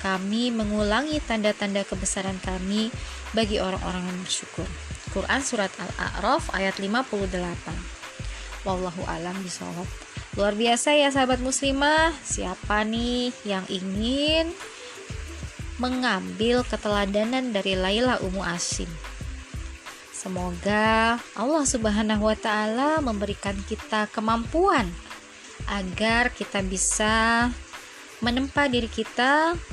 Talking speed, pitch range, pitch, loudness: 90 wpm, 195-245 Hz, 215 Hz, -25 LUFS